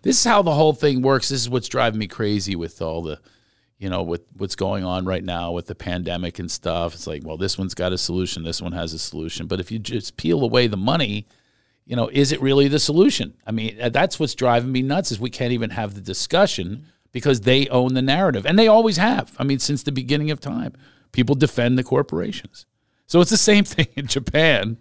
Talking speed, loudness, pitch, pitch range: 235 wpm, -20 LUFS, 120 Hz, 95-140 Hz